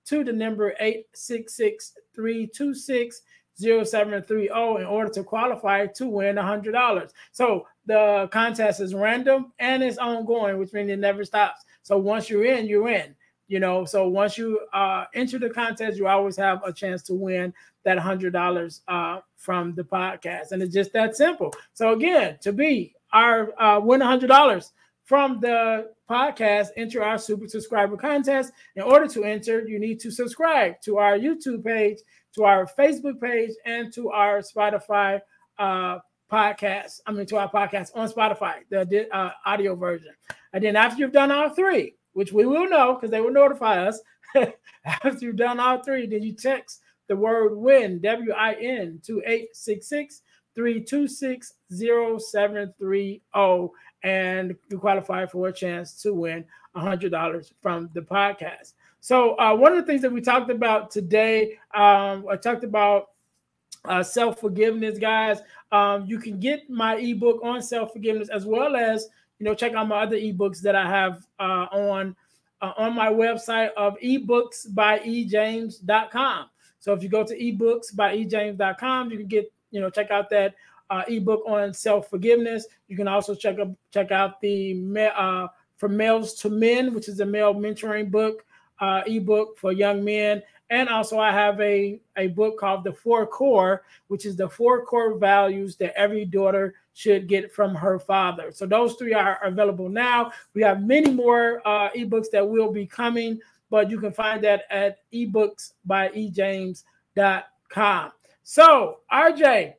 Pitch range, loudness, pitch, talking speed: 200-230 Hz, -23 LUFS, 215 Hz, 165 wpm